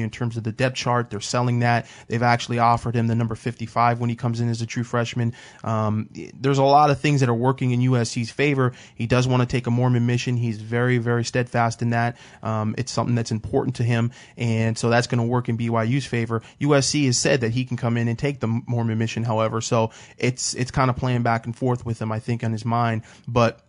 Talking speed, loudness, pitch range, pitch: 245 wpm, -22 LUFS, 115-125 Hz, 120 Hz